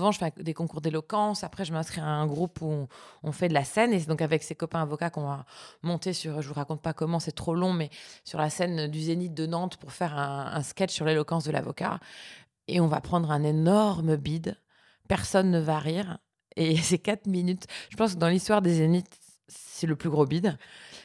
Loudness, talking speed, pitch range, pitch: -28 LUFS, 230 wpm, 155-180 Hz, 165 Hz